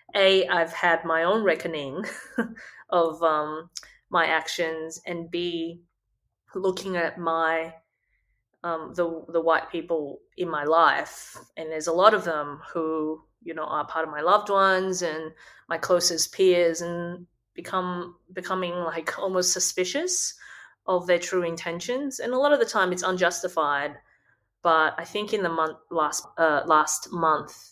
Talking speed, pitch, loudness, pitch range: 150 wpm, 170 Hz, -25 LUFS, 160-185 Hz